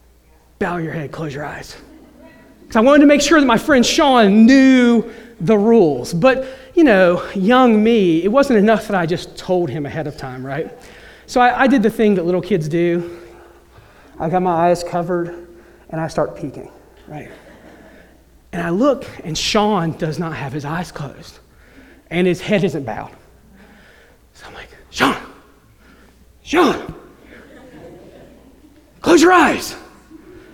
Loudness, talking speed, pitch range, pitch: -15 LUFS, 155 wpm, 165-260 Hz, 190 Hz